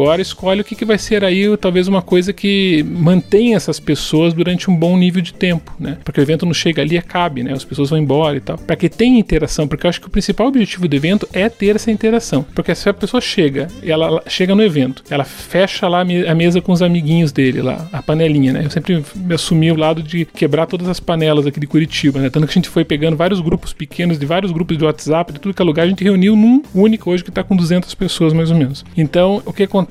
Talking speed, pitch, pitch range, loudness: 255 wpm, 175 Hz, 155-190 Hz, -15 LUFS